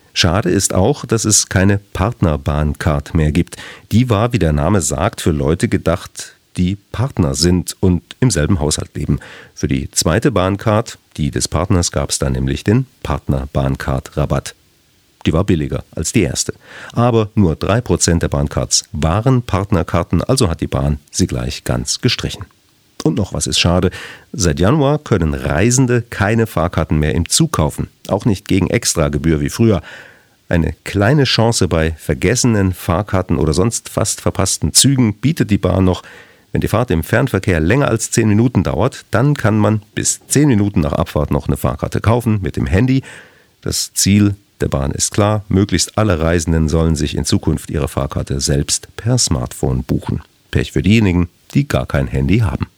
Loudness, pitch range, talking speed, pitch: -16 LUFS, 80-110 Hz, 170 wpm, 95 Hz